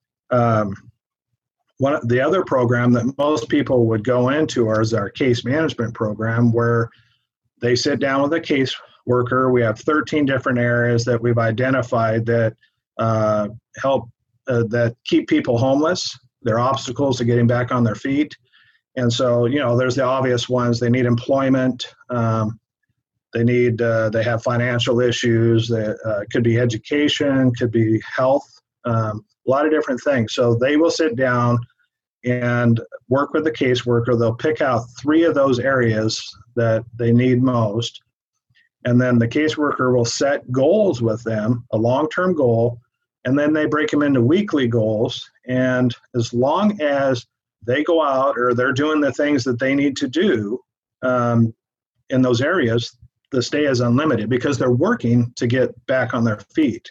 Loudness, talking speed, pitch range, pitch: -19 LUFS, 170 wpm, 115-135 Hz, 125 Hz